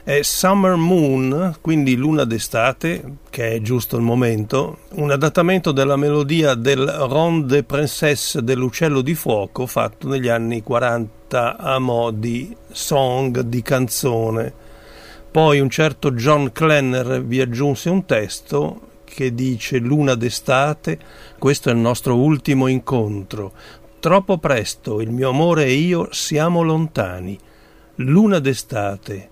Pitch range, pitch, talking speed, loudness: 115-150 Hz, 135 Hz, 125 wpm, -18 LUFS